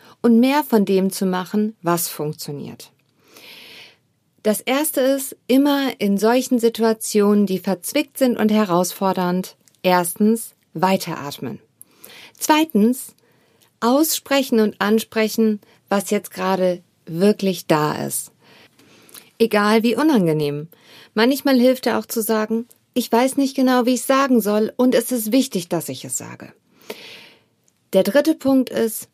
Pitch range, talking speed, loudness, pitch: 190-250 Hz, 130 wpm, -19 LUFS, 220 Hz